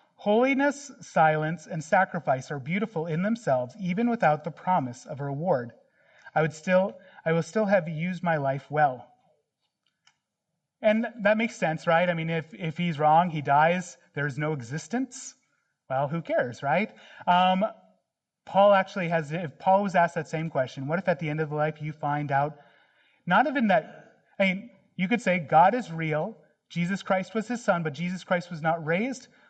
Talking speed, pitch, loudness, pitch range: 185 wpm, 170 Hz, -26 LUFS, 155-195 Hz